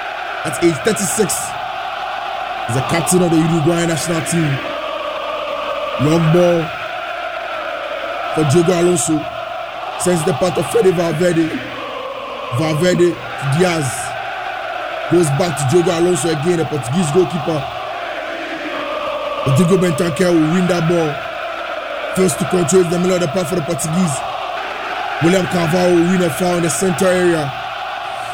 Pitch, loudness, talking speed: 185 Hz, -17 LUFS, 130 wpm